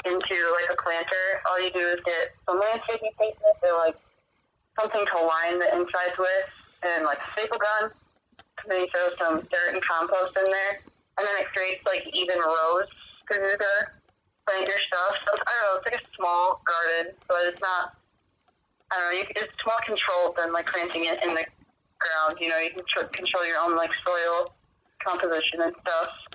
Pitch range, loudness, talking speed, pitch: 170-195 Hz, -26 LUFS, 200 wpm, 180 Hz